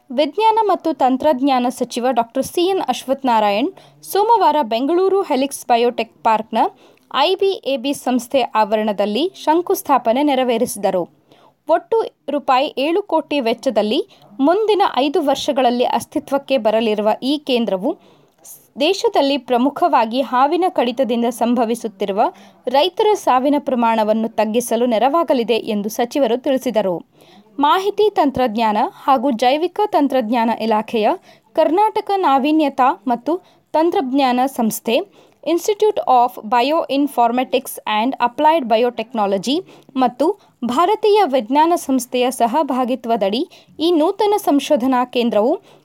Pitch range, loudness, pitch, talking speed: 235-320 Hz, -17 LUFS, 270 Hz, 90 wpm